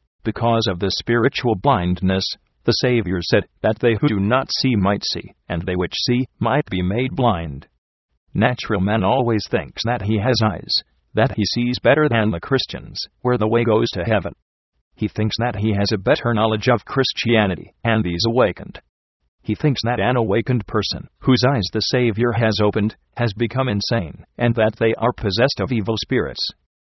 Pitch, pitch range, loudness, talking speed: 110 Hz, 95-120 Hz, -20 LUFS, 180 wpm